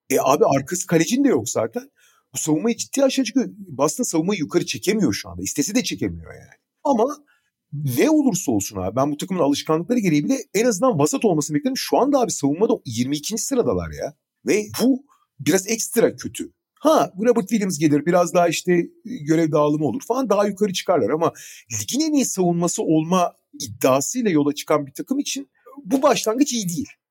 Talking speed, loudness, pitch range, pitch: 175 wpm, -21 LUFS, 155-255 Hz, 200 Hz